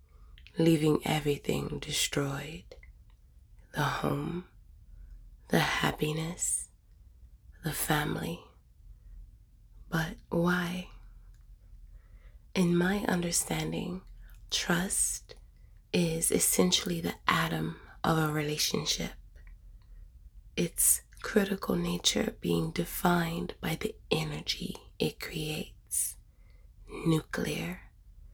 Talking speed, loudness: 70 wpm, -30 LUFS